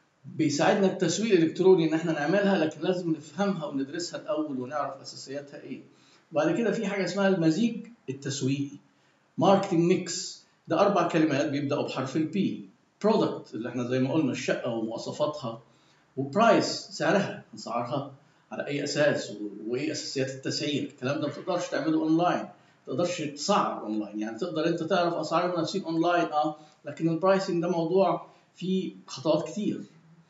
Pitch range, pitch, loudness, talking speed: 145-185 Hz, 165 Hz, -28 LUFS, 145 wpm